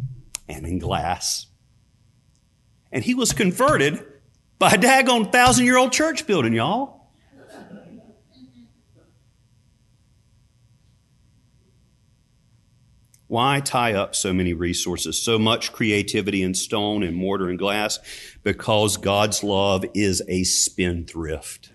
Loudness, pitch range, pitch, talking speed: -20 LUFS, 100-130 Hz, 115 Hz, 100 wpm